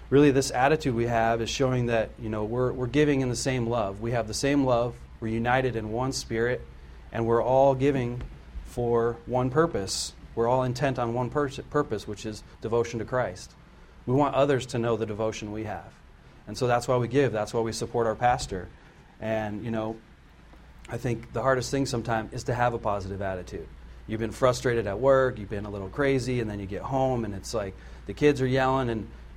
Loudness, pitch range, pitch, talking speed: -27 LUFS, 110-130 Hz, 120 Hz, 215 wpm